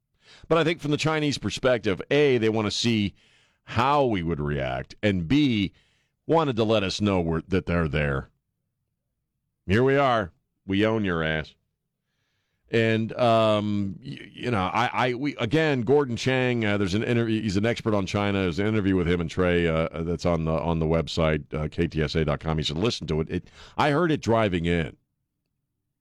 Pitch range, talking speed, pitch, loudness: 85-120 Hz, 185 wpm, 105 Hz, -24 LUFS